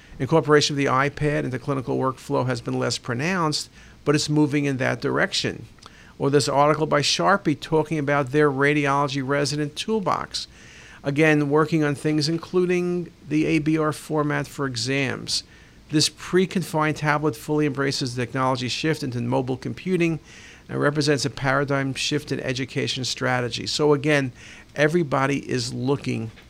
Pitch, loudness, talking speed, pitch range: 145 Hz, -23 LUFS, 145 wpm, 135-155 Hz